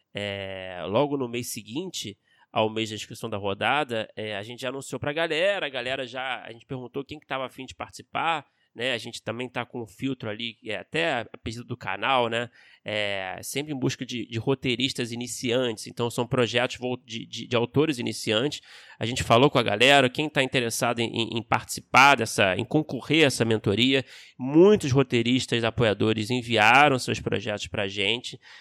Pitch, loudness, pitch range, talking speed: 120 Hz, -25 LUFS, 110-135 Hz, 190 wpm